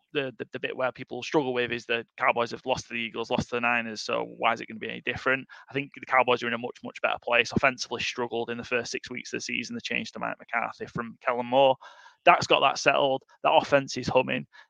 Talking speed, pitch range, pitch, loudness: 270 wpm, 120-135 Hz, 125 Hz, -27 LUFS